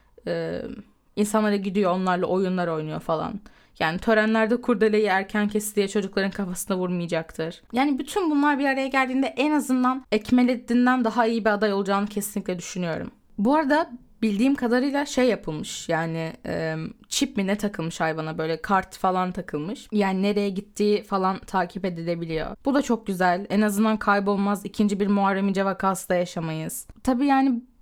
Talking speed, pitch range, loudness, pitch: 150 wpm, 185-240 Hz, -24 LUFS, 205 Hz